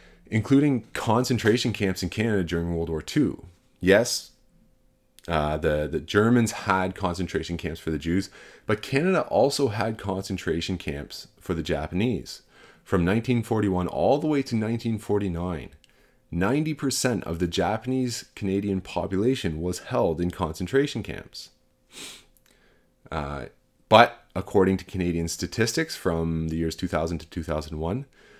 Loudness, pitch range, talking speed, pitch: -25 LUFS, 85-115 Hz, 125 wpm, 95 Hz